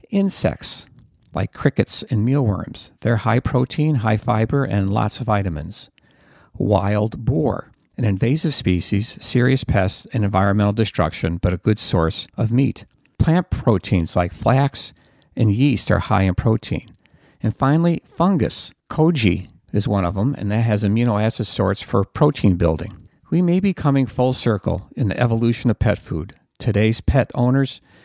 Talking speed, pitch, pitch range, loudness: 150 wpm, 110 Hz, 100-130 Hz, -20 LUFS